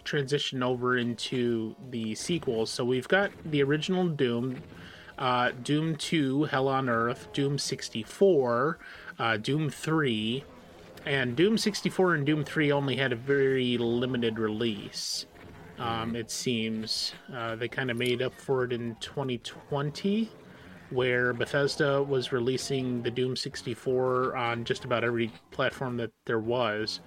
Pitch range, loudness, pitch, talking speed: 115-140 Hz, -29 LUFS, 125 Hz, 135 wpm